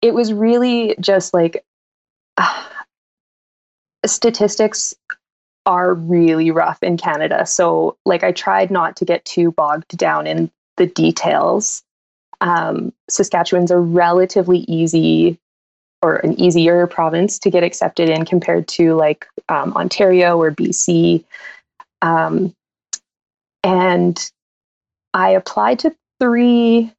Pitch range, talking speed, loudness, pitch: 165-200 Hz, 115 wpm, -15 LUFS, 175 Hz